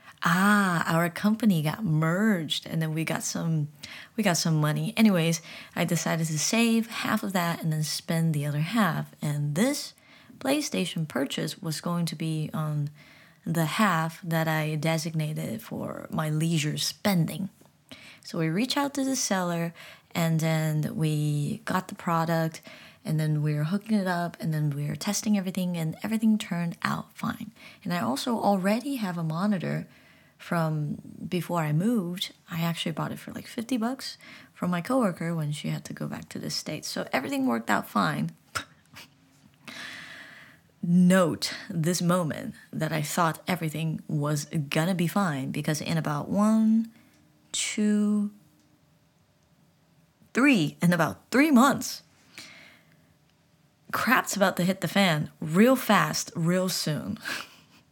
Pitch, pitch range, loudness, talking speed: 175 Hz, 160-210 Hz, -27 LUFS, 150 wpm